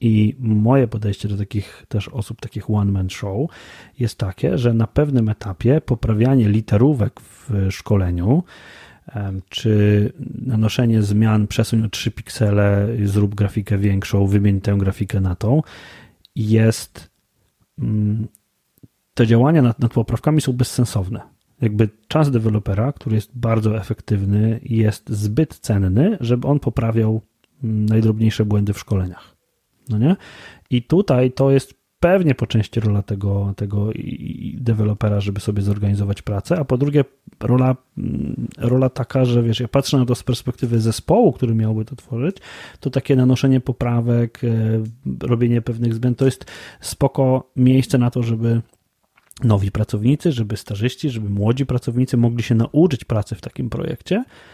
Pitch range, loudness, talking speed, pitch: 105-125 Hz, -19 LUFS, 135 wpm, 115 Hz